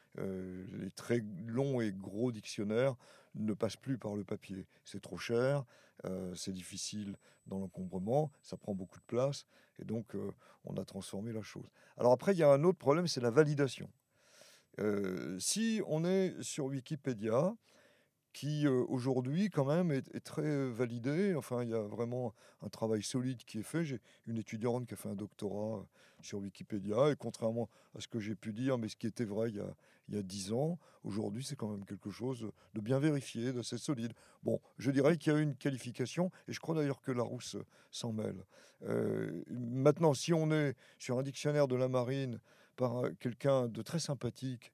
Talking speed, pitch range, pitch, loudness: 190 wpm, 105-140 Hz, 120 Hz, -37 LUFS